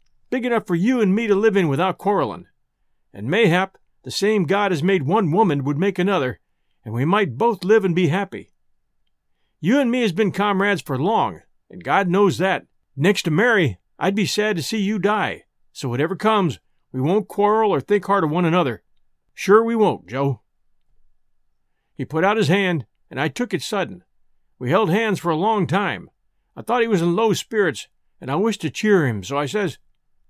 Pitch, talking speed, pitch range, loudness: 195 Hz, 200 wpm, 155-210 Hz, -20 LUFS